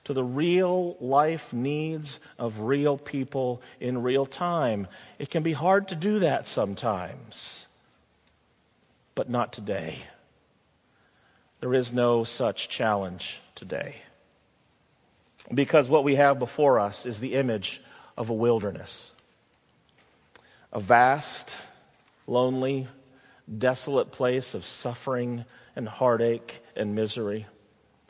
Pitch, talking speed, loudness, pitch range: 125 Hz, 110 wpm, -27 LUFS, 115-145 Hz